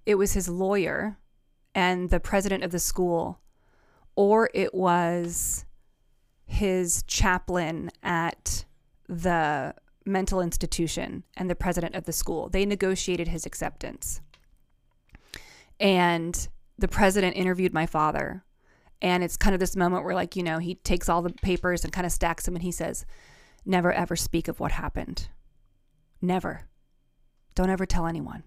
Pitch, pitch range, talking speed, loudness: 180 Hz, 170-190 Hz, 145 wpm, -27 LUFS